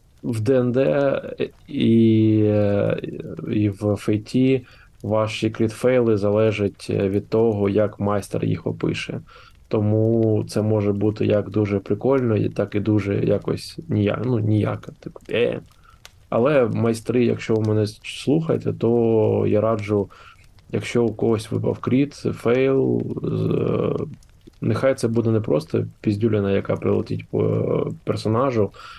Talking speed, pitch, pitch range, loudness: 125 wpm, 110 Hz, 105-120 Hz, -21 LUFS